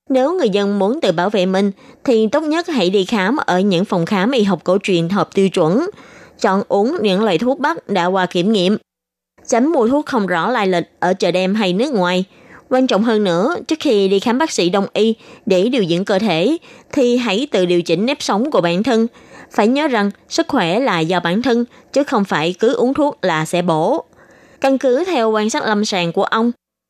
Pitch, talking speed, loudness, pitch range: 210 Hz, 230 wpm, -16 LUFS, 185-250 Hz